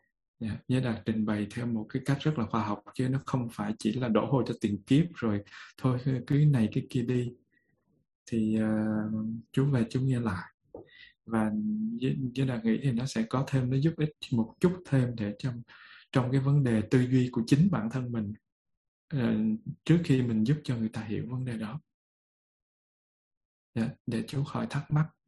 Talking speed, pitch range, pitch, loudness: 200 wpm, 110-135 Hz, 120 Hz, -30 LUFS